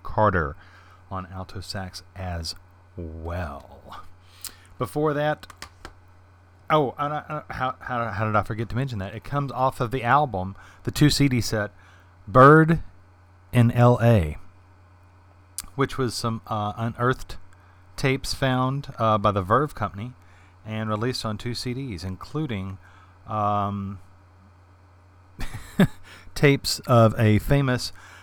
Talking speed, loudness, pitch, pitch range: 115 wpm, -23 LUFS, 100 Hz, 95-125 Hz